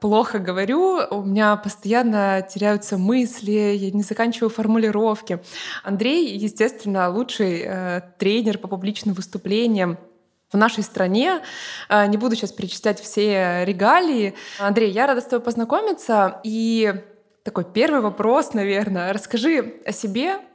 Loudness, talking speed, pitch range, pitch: -21 LUFS, 120 wpm, 200-230 Hz, 210 Hz